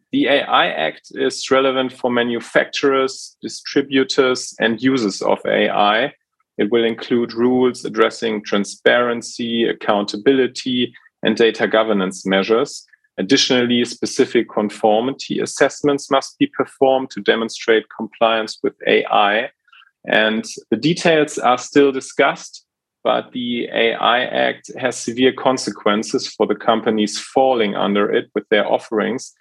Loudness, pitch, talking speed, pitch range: -18 LUFS, 125 Hz, 115 wpm, 110-135 Hz